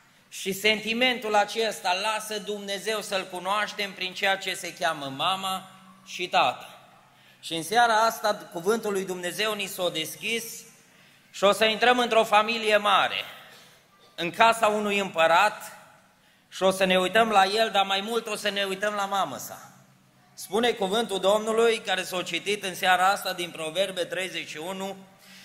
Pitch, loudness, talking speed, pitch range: 195 Hz, -25 LUFS, 160 wpm, 185-215 Hz